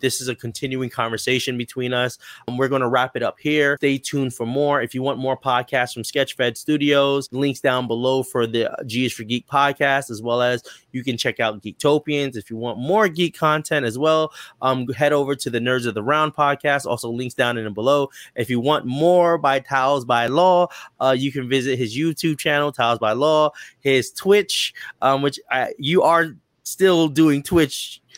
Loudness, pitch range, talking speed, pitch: -20 LUFS, 125-145 Hz, 205 wpm, 135 Hz